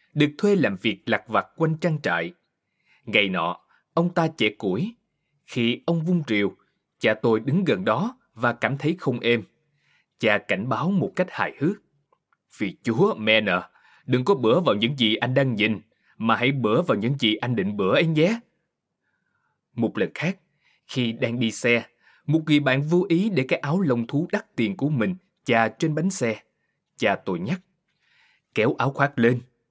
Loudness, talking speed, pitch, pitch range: -23 LUFS, 185 wpm, 140 Hz, 115-175 Hz